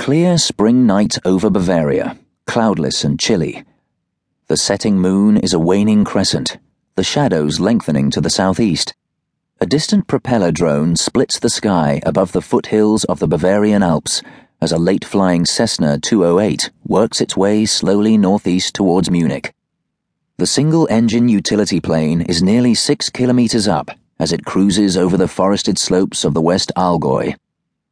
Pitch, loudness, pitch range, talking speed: 100 Hz, -15 LUFS, 90-120 Hz, 150 wpm